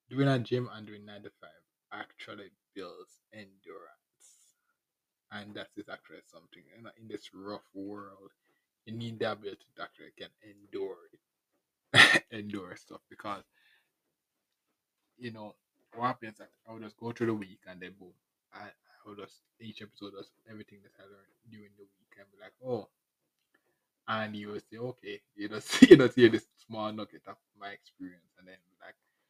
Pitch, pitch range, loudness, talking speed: 105 Hz, 100-115 Hz, -27 LUFS, 175 wpm